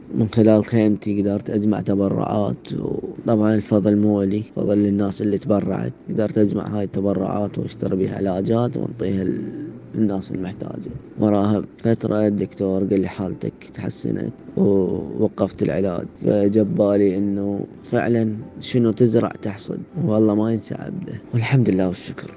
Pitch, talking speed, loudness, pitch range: 105 Hz, 125 wpm, -21 LUFS, 100-110 Hz